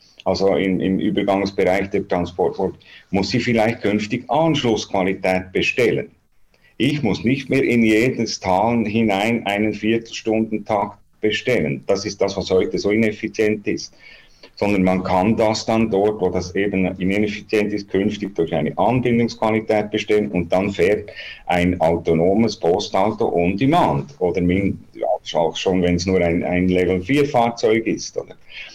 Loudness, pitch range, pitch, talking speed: -19 LUFS, 95-115 Hz, 105 Hz, 140 wpm